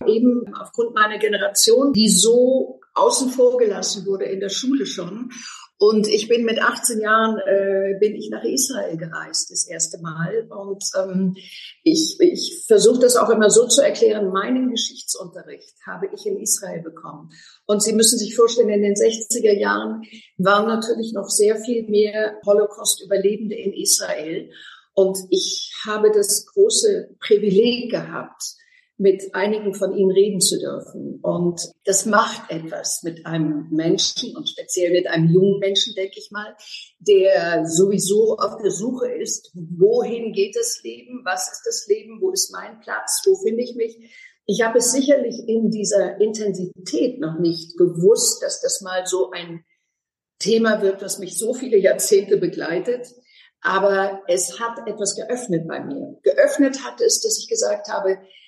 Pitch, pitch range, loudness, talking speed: 215 Hz, 195-250 Hz, -19 LUFS, 160 wpm